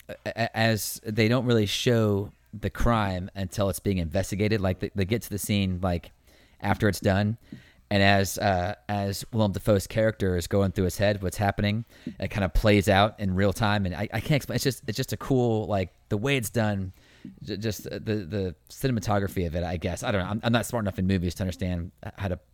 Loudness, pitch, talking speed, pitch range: -27 LUFS, 100 Hz, 215 wpm, 95-110 Hz